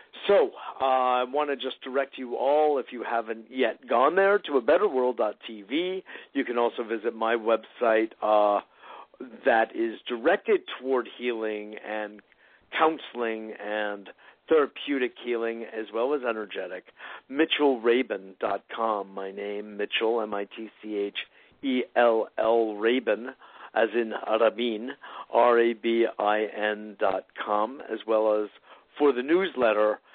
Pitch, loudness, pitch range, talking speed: 115 Hz, -27 LUFS, 105-130 Hz, 130 wpm